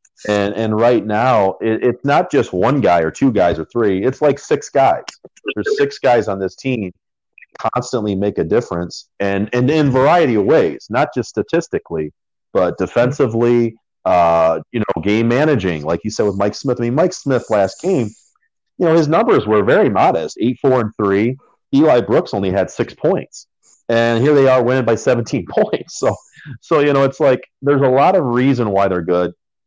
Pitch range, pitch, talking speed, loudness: 100-135 Hz, 120 Hz, 190 wpm, -16 LUFS